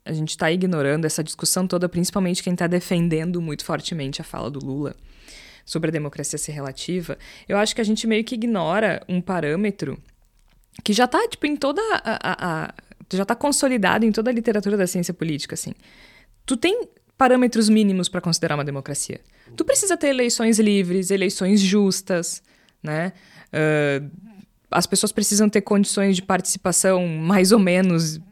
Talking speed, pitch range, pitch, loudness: 165 wpm, 160-215 Hz, 185 Hz, -21 LUFS